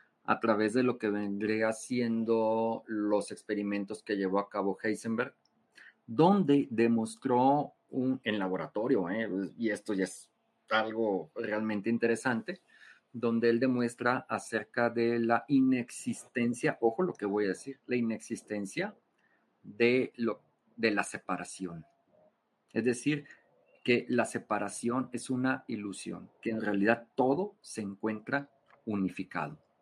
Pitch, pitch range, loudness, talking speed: 115 Hz, 105-125 Hz, -32 LUFS, 125 wpm